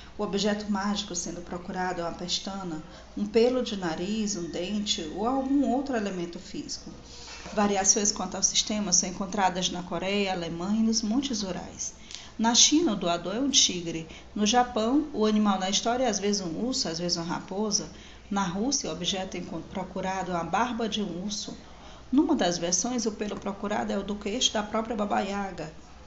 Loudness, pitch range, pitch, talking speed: -27 LUFS, 180-220 Hz, 200 Hz, 185 wpm